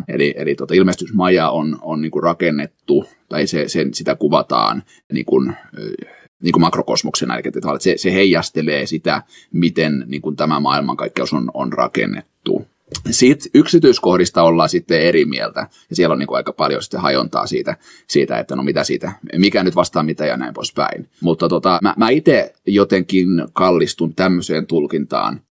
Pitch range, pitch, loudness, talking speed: 80-95 Hz, 85 Hz, -16 LUFS, 155 wpm